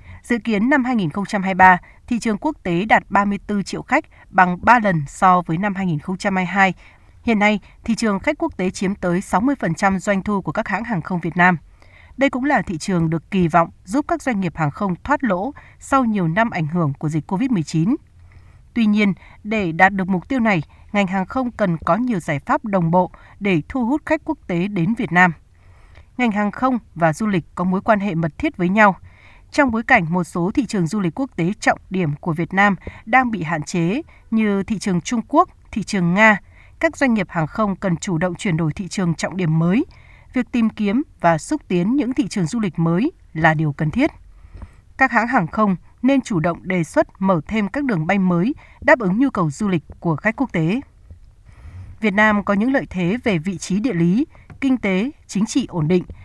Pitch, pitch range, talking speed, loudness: 195 Hz, 175-230 Hz, 220 wpm, -19 LUFS